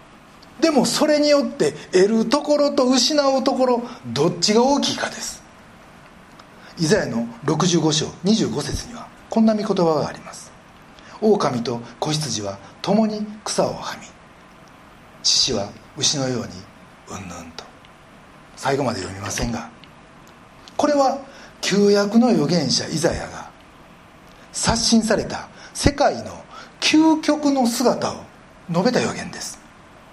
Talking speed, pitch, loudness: 230 characters per minute, 215 Hz, -20 LUFS